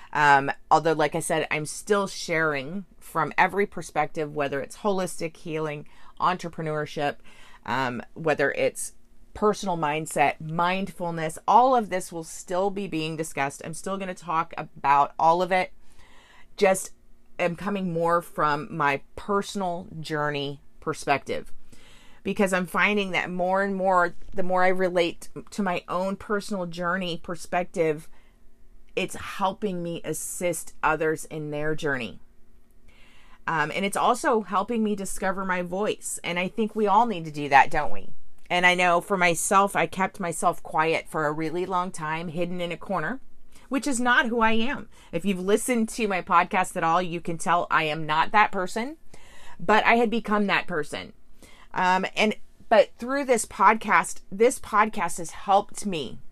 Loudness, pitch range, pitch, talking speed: -25 LUFS, 160-200 Hz, 180 Hz, 160 wpm